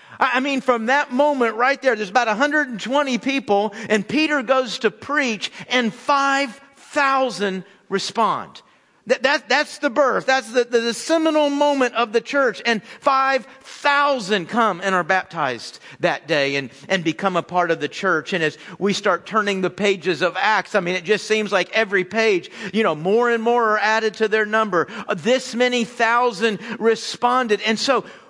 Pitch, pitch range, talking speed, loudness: 230 Hz, 205-265 Hz, 175 wpm, -20 LUFS